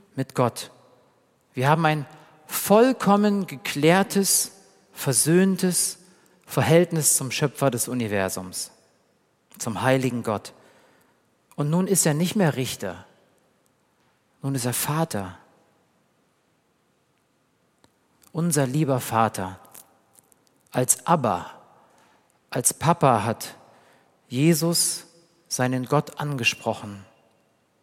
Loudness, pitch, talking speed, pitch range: -23 LUFS, 145 Hz, 85 wpm, 120-170 Hz